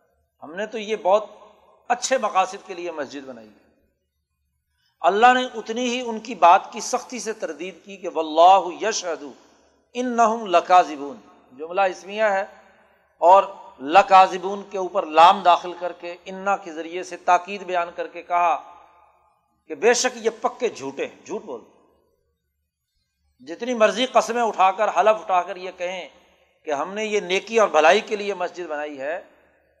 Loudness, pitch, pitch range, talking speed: -21 LUFS, 190 Hz, 170-215 Hz, 160 wpm